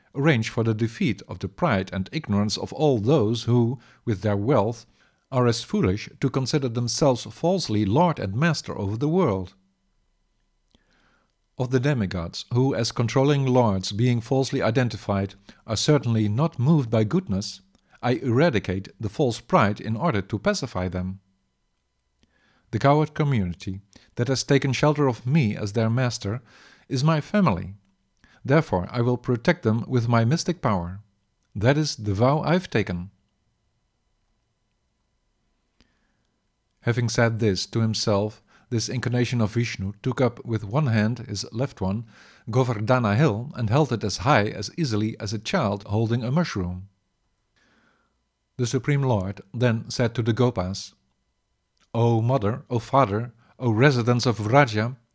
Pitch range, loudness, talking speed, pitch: 100-130 Hz, -24 LUFS, 145 wpm, 115 Hz